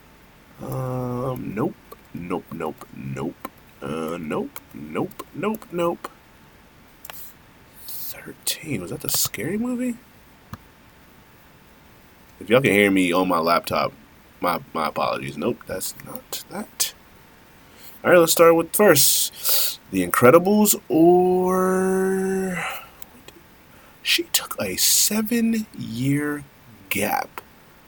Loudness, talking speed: -21 LUFS, 95 wpm